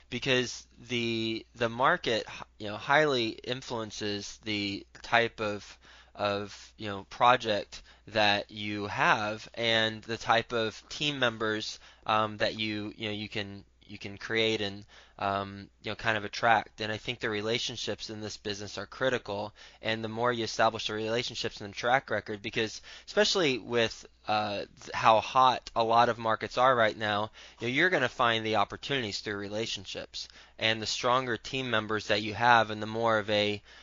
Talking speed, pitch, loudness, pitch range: 170 wpm, 110 Hz, -29 LUFS, 105-115 Hz